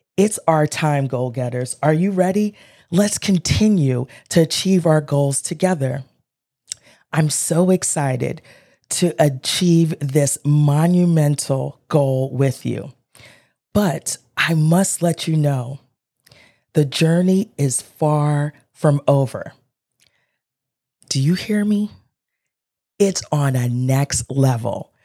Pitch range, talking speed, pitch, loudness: 135-170 Hz, 110 wpm, 145 Hz, -18 LUFS